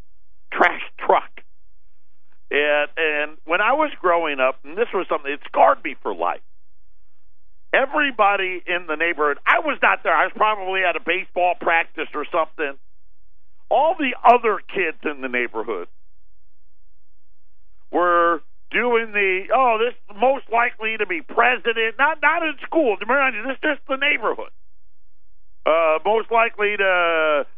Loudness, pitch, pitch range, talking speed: -20 LUFS, 175 Hz, 140-235 Hz, 145 wpm